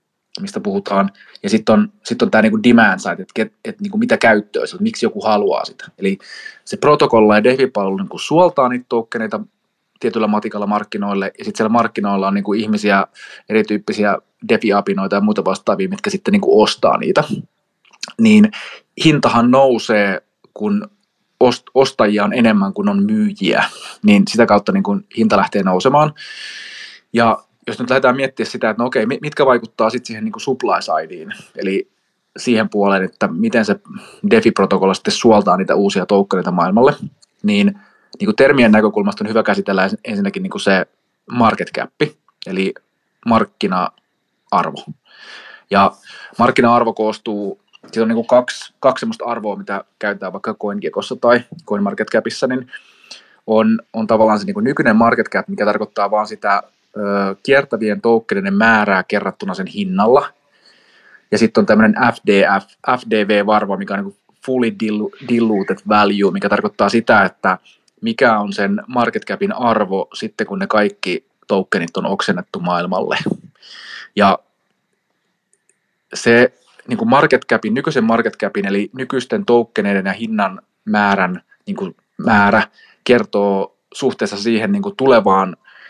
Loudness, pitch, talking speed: -16 LUFS, 120 Hz, 140 wpm